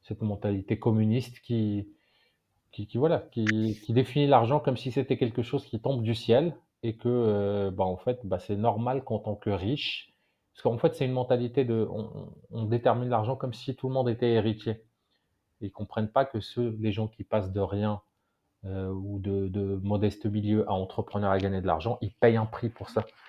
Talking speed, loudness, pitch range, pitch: 210 wpm, -29 LUFS, 100-120 Hz, 110 Hz